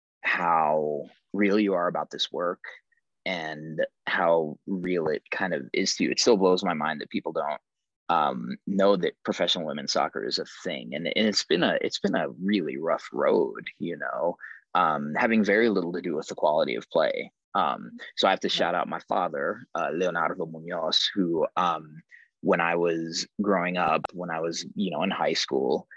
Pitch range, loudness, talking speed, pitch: 80-95 Hz, -26 LUFS, 195 wpm, 85 Hz